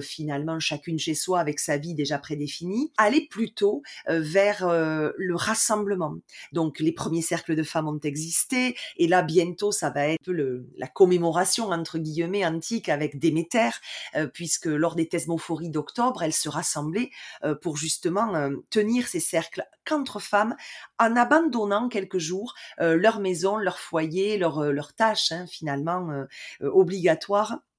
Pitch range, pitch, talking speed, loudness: 155-205 Hz, 170 Hz, 160 wpm, -25 LUFS